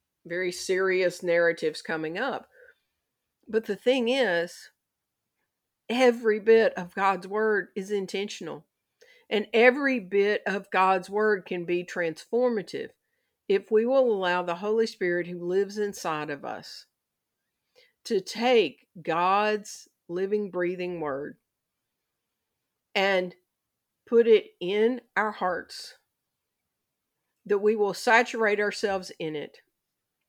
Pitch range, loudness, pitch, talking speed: 180-230 Hz, -26 LUFS, 205 Hz, 110 wpm